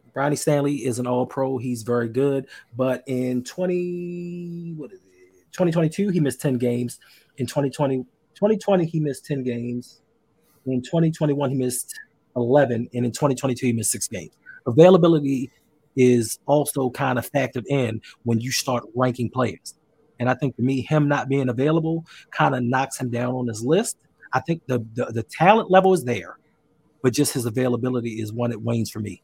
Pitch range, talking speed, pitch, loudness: 120-150 Hz, 180 wpm, 130 Hz, -22 LUFS